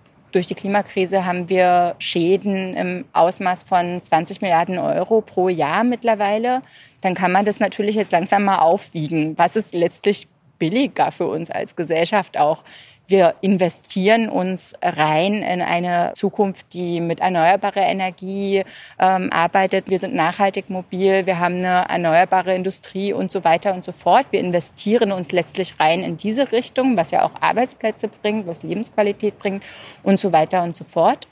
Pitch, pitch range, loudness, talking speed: 185 Hz, 170-200 Hz, -19 LUFS, 155 wpm